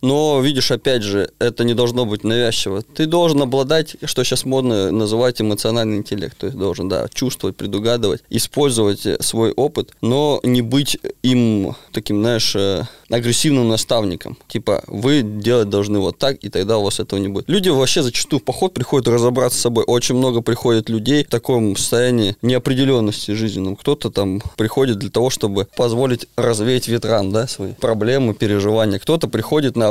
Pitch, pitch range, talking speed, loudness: 120 Hz, 105-130 Hz, 165 wpm, -18 LUFS